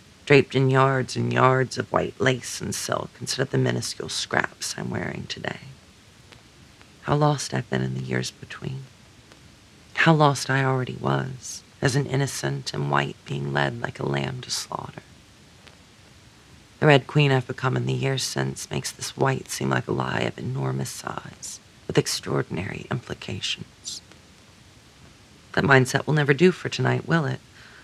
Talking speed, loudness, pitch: 160 wpm, -24 LUFS, 120 Hz